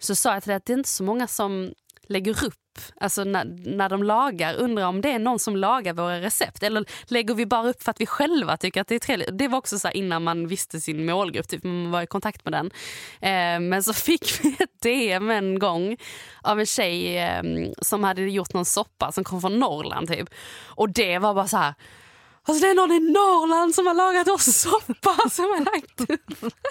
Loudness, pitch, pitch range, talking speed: -23 LUFS, 205 Hz, 185-245 Hz, 230 wpm